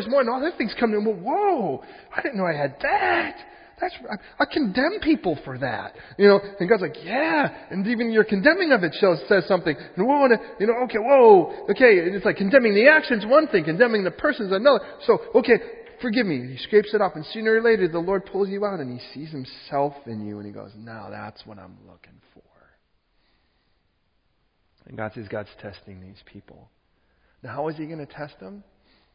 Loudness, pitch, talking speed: -21 LUFS, 195 Hz, 210 wpm